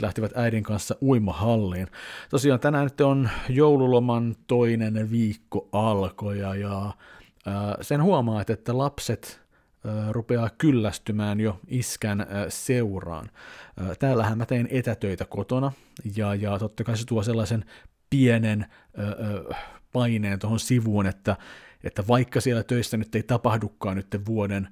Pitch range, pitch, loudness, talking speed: 105-120 Hz, 110 Hz, -25 LUFS, 110 wpm